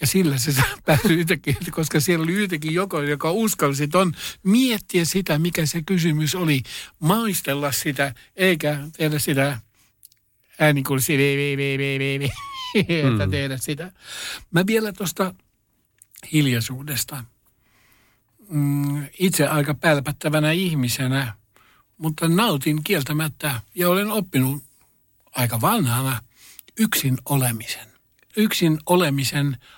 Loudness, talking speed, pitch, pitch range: -21 LUFS, 100 wpm, 150 Hz, 135-175 Hz